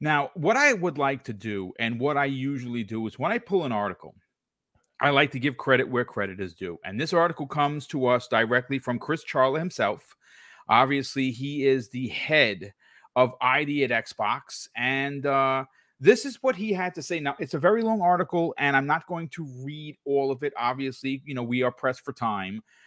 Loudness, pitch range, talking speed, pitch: -25 LUFS, 125-155 Hz, 205 wpm, 135 Hz